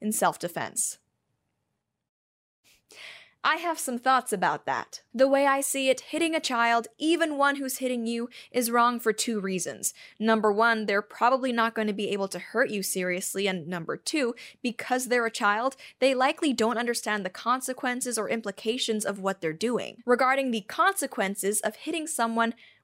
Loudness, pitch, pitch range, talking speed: -27 LUFS, 235 Hz, 210-260 Hz, 170 wpm